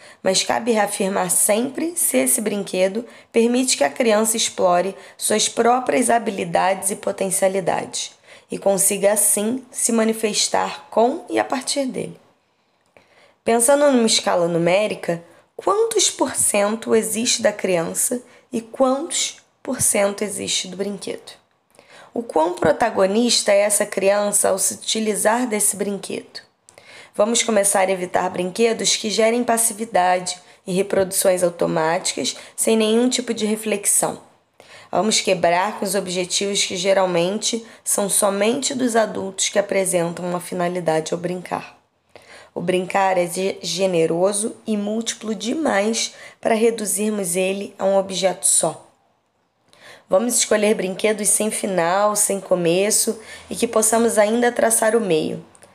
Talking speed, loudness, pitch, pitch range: 125 wpm, -19 LUFS, 210 Hz, 190-230 Hz